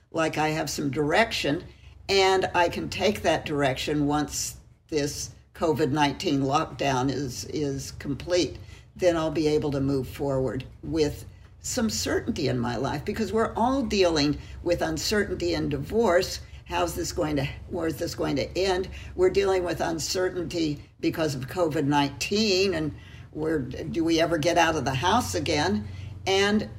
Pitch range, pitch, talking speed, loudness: 140-175 Hz, 155 Hz, 150 wpm, -26 LUFS